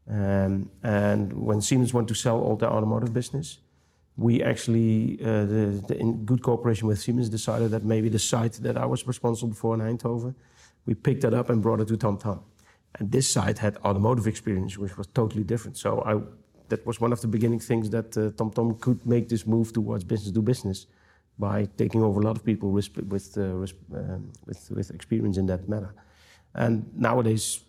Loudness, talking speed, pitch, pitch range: -26 LUFS, 205 wpm, 110 Hz, 100-115 Hz